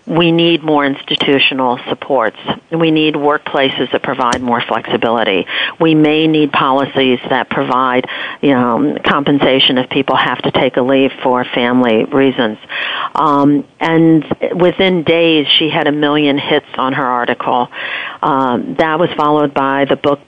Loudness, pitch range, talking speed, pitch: -13 LUFS, 130-155 Hz, 150 wpm, 145 Hz